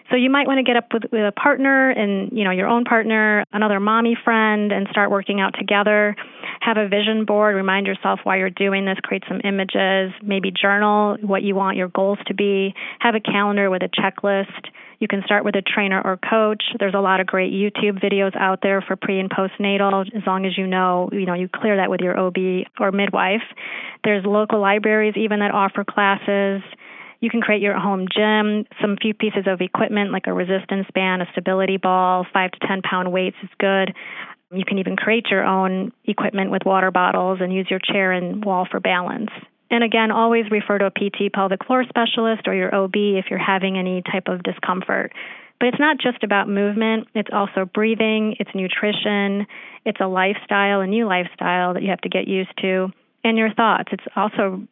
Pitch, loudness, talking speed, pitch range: 200 Hz, -19 LUFS, 205 wpm, 190-215 Hz